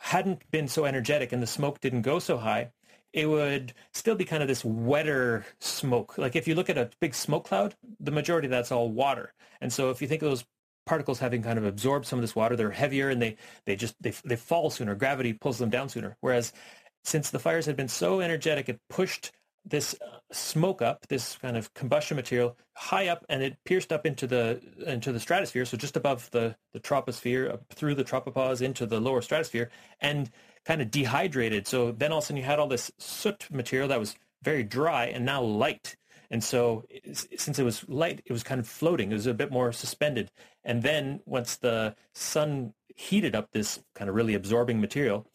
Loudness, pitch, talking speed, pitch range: -29 LUFS, 130 Hz, 215 wpm, 120-150 Hz